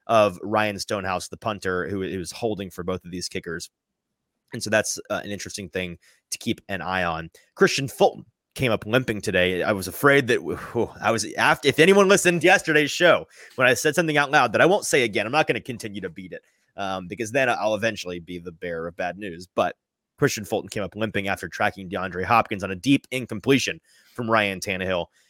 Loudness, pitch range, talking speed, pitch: -23 LUFS, 95-125 Hz, 220 wpm, 100 Hz